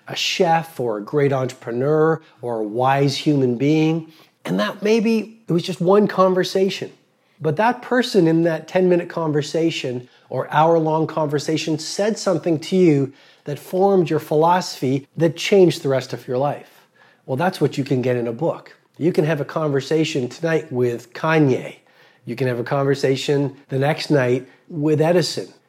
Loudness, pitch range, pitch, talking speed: -20 LUFS, 140-175 Hz, 155 Hz, 170 wpm